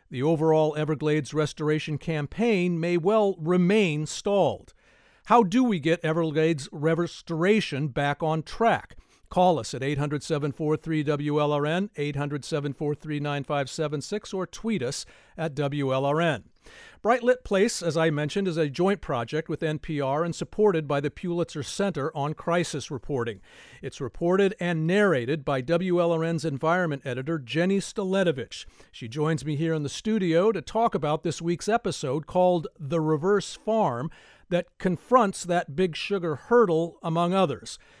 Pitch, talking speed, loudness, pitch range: 165 Hz, 130 wpm, -26 LUFS, 150-185 Hz